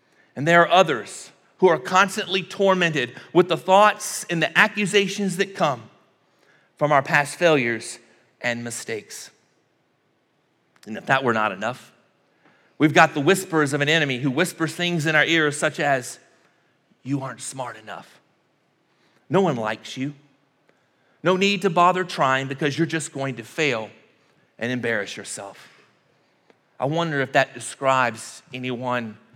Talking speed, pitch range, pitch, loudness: 145 wpm, 130-180 Hz, 150 Hz, -21 LUFS